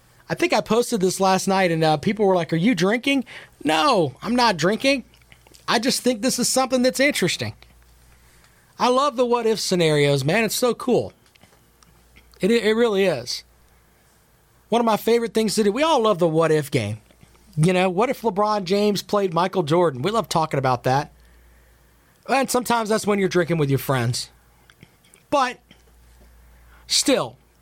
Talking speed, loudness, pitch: 175 wpm, -20 LUFS, 185 Hz